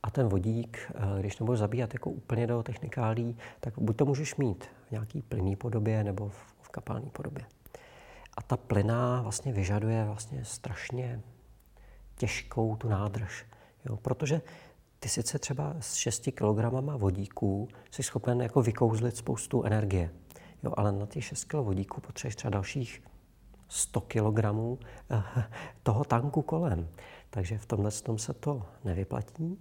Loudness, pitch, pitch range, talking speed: -32 LUFS, 115 Hz, 105-130 Hz, 145 wpm